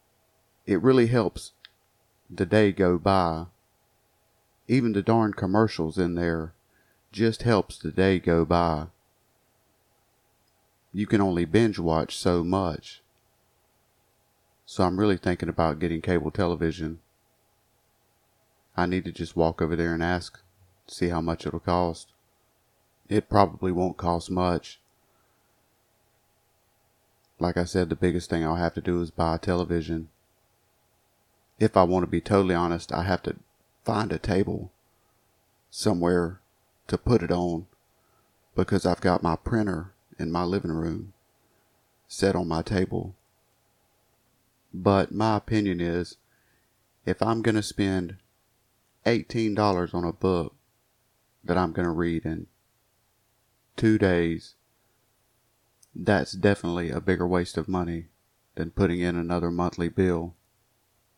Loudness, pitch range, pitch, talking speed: -26 LUFS, 85-110 Hz, 95 Hz, 130 wpm